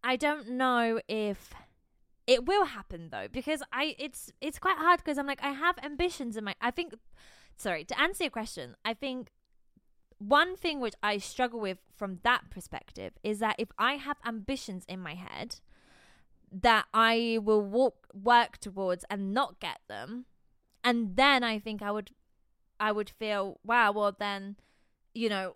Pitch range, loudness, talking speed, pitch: 210-280 Hz, -30 LUFS, 170 wpm, 235 Hz